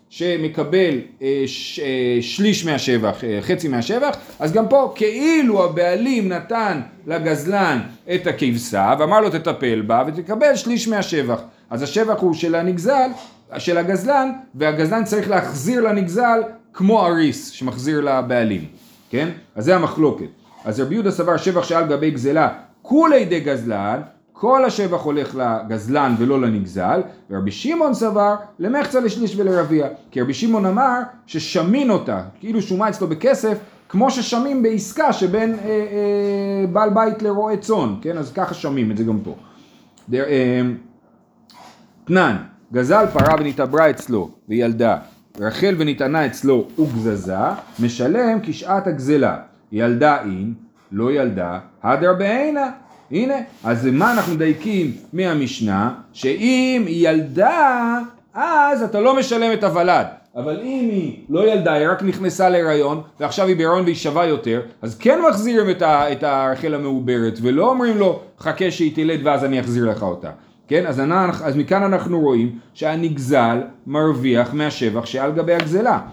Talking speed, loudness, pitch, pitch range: 135 wpm, -18 LUFS, 170 Hz, 135-215 Hz